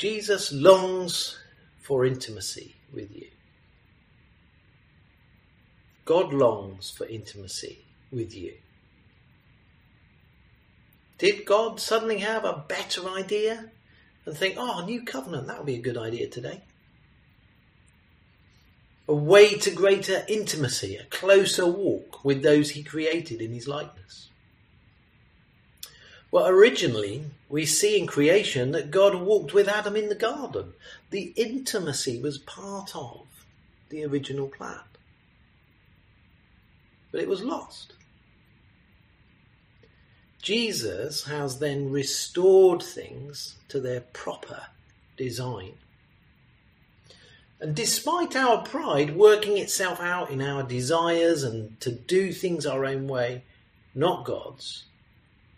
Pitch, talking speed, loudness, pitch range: 160 Hz, 110 wpm, -25 LUFS, 135-200 Hz